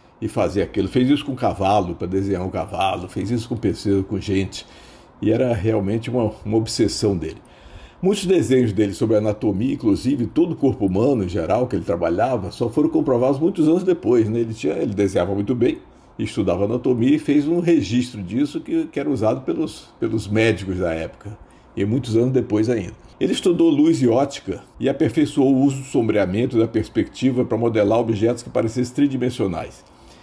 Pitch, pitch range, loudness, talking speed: 115 Hz, 105-145 Hz, -20 LUFS, 185 wpm